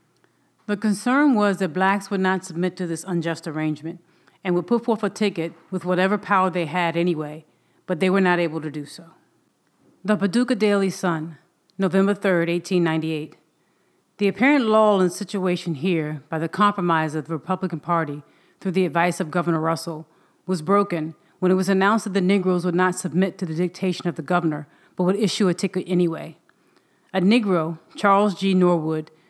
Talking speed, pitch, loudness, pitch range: 180 wpm, 180 Hz, -22 LUFS, 165-195 Hz